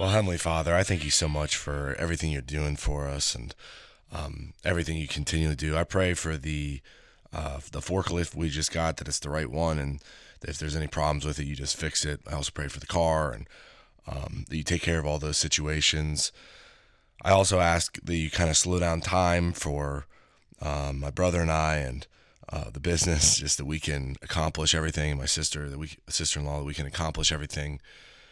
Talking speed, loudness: 215 wpm, -28 LUFS